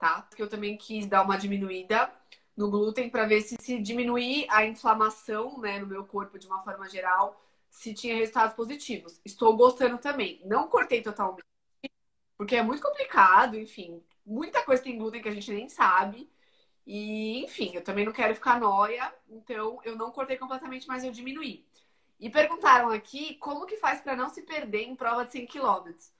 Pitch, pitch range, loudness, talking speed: 225 Hz, 205-255 Hz, -27 LUFS, 180 wpm